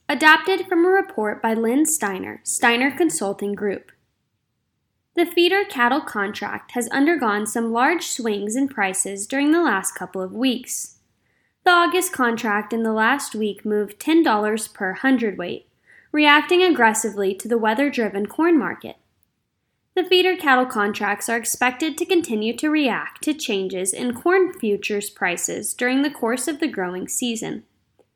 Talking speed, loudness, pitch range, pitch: 145 wpm, -20 LUFS, 210-310 Hz, 245 Hz